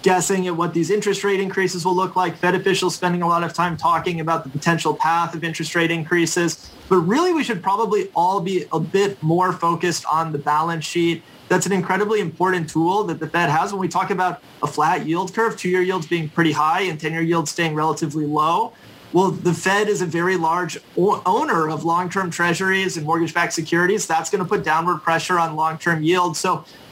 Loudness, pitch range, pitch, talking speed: -20 LUFS, 165-185 Hz, 175 Hz, 205 wpm